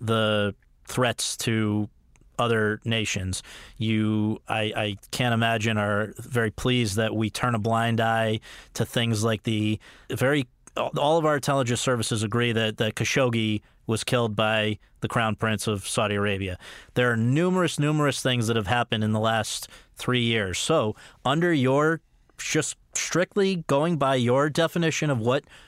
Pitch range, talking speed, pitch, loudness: 110-130 Hz, 155 wpm, 115 Hz, -25 LUFS